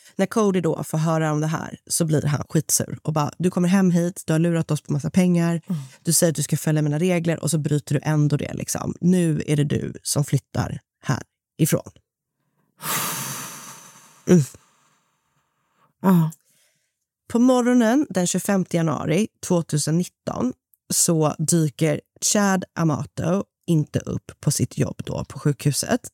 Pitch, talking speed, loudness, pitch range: 160 Hz, 155 wpm, -22 LUFS, 150-180 Hz